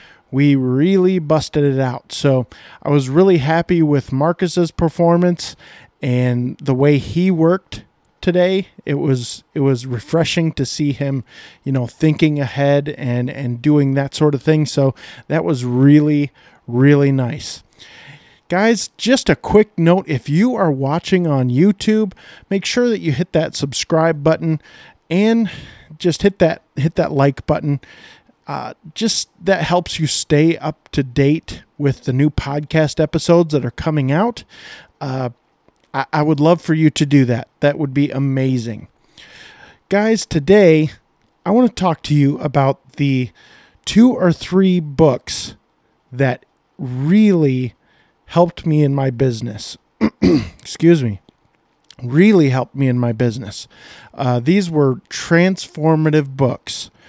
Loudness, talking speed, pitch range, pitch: -16 LUFS, 145 wpm, 135-170 Hz, 150 Hz